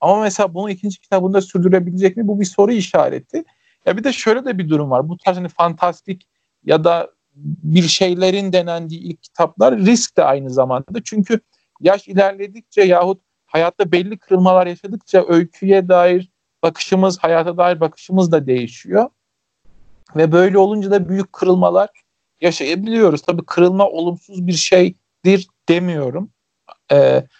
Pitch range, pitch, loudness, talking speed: 170-200 Hz, 185 Hz, -16 LUFS, 140 wpm